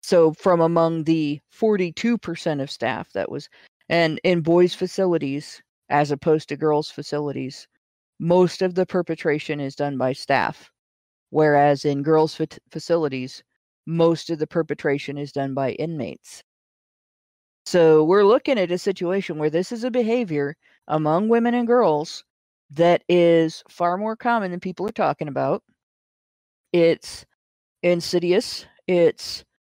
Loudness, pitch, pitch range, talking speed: -21 LUFS, 165 Hz, 145-180 Hz, 135 wpm